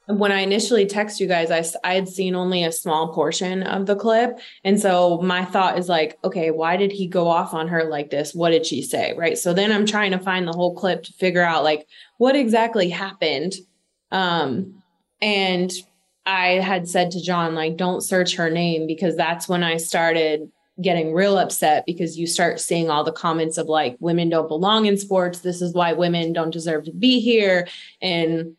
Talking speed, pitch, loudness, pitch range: 205 wpm, 180 Hz, -20 LUFS, 165-190 Hz